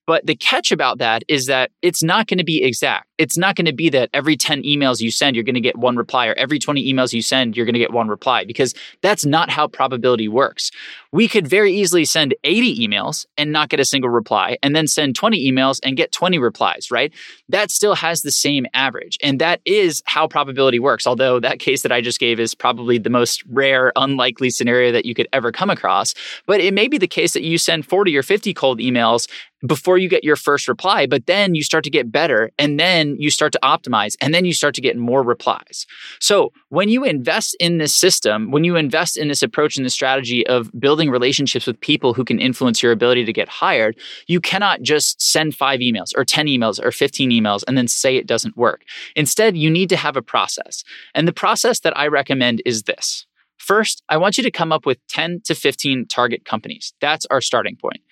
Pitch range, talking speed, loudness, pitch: 125-165 Hz, 230 wpm, -17 LUFS, 145 Hz